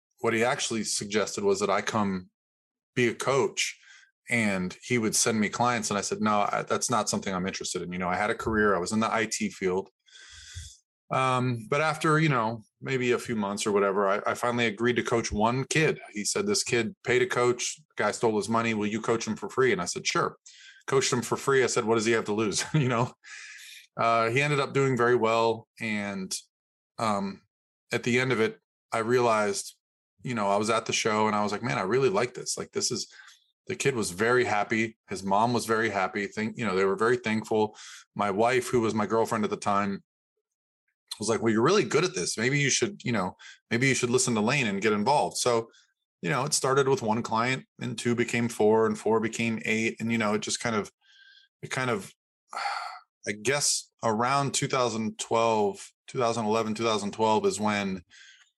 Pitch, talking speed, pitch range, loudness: 115 Hz, 215 wpm, 105-130 Hz, -27 LUFS